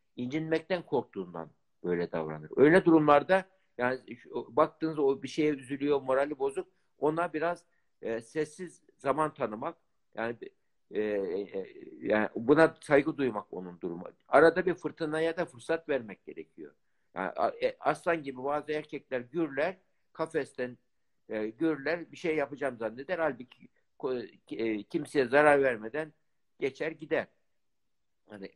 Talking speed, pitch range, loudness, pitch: 120 wpm, 125-165 Hz, -30 LUFS, 150 Hz